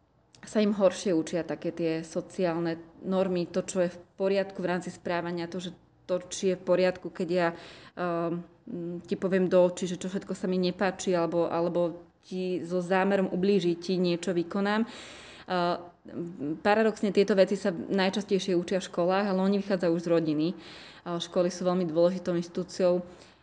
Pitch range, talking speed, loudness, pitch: 170-190 Hz, 165 wpm, -29 LUFS, 180 Hz